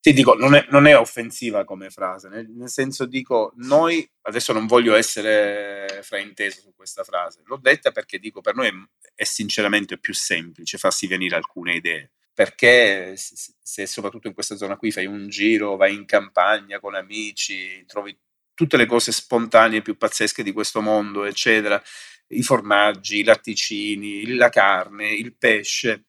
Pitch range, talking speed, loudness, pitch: 100-120 Hz, 170 wpm, -19 LUFS, 105 Hz